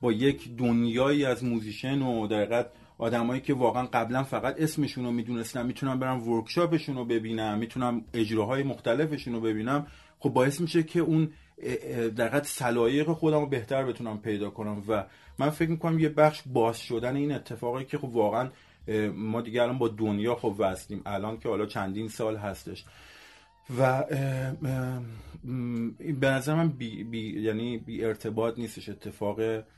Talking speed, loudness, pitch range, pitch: 150 wpm, -29 LUFS, 110-135 Hz, 120 Hz